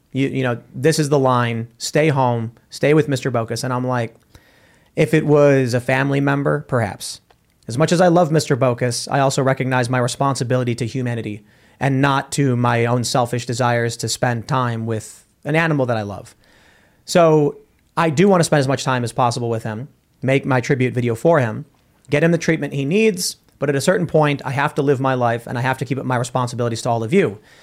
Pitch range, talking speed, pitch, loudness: 120-145 Hz, 220 wpm, 130 Hz, -18 LUFS